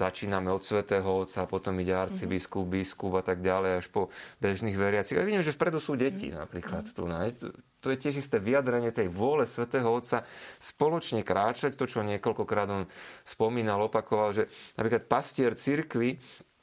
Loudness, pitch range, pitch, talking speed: -30 LUFS, 95-125 Hz, 105 Hz, 160 wpm